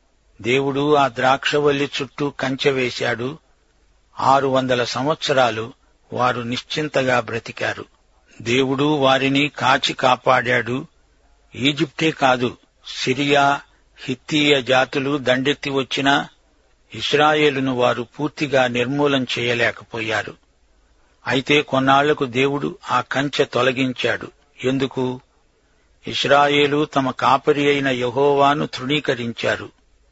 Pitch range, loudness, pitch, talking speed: 125-145 Hz, -19 LUFS, 135 Hz, 80 wpm